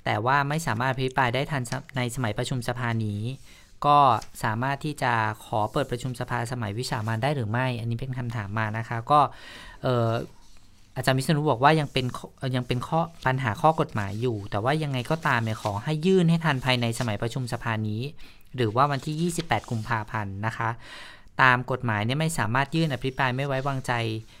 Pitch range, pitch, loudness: 115-140 Hz, 125 Hz, -26 LUFS